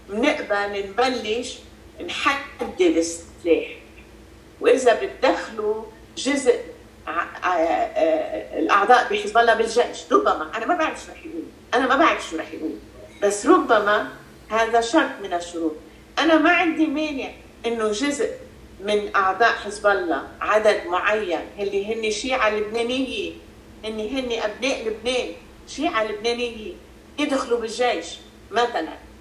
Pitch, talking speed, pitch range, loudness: 235 Hz, 125 wpm, 210-290 Hz, -22 LUFS